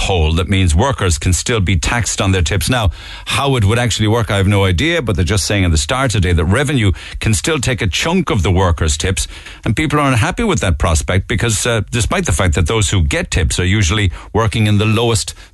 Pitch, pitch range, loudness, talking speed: 100 Hz, 90-115 Hz, -15 LUFS, 250 wpm